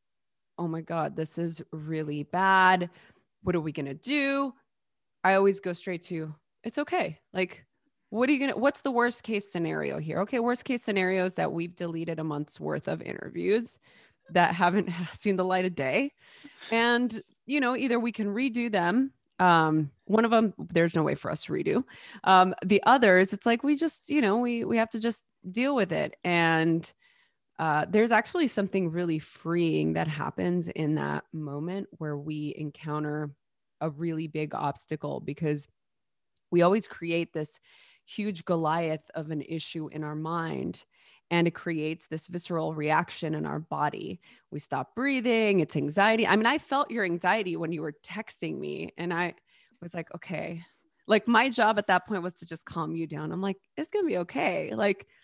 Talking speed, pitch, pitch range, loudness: 180 wpm, 180 Hz, 160-225 Hz, -28 LUFS